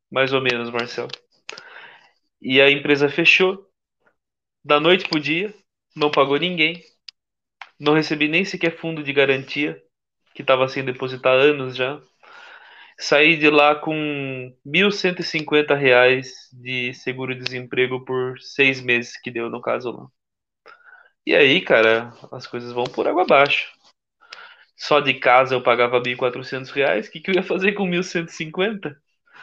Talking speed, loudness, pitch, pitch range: 150 wpm, -19 LUFS, 145 Hz, 130-165 Hz